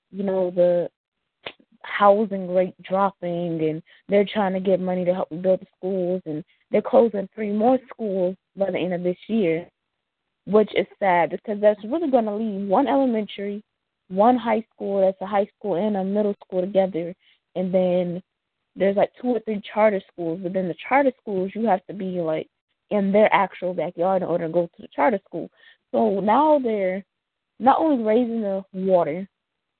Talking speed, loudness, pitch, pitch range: 185 wpm, -22 LUFS, 195 Hz, 180-215 Hz